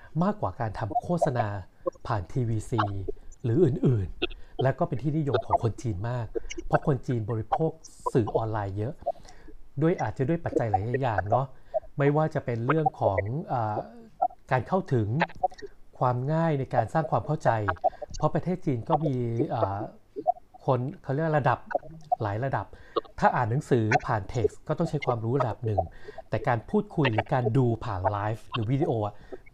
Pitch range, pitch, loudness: 115-155 Hz, 135 Hz, -28 LUFS